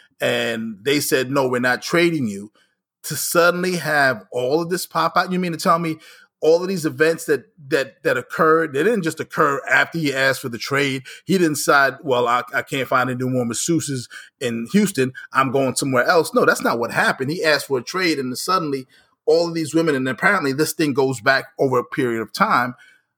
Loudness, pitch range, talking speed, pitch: -19 LUFS, 130-165 Hz, 210 wpm, 140 Hz